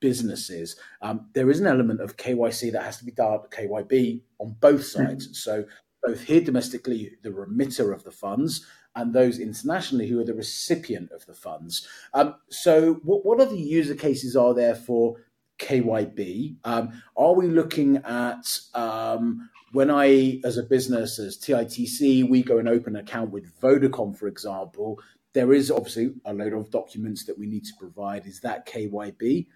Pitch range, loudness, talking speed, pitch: 110-135 Hz, -24 LUFS, 175 wpm, 120 Hz